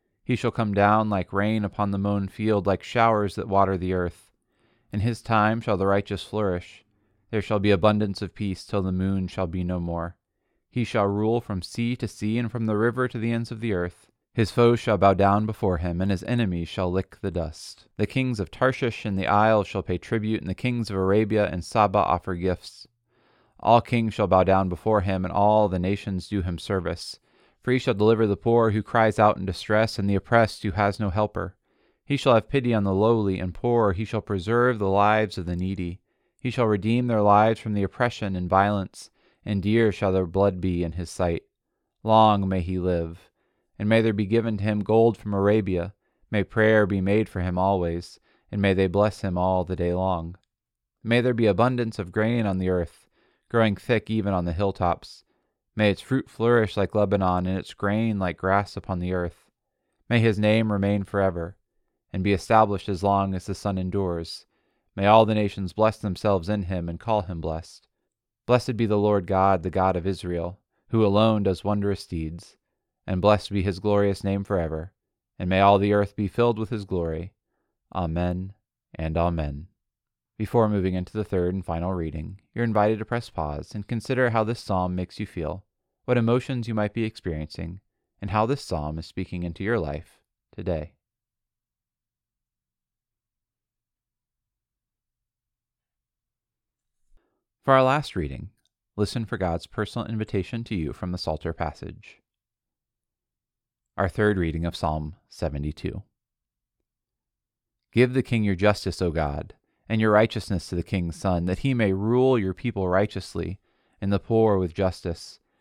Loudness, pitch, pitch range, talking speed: -24 LUFS, 100 Hz, 90-110 Hz, 185 wpm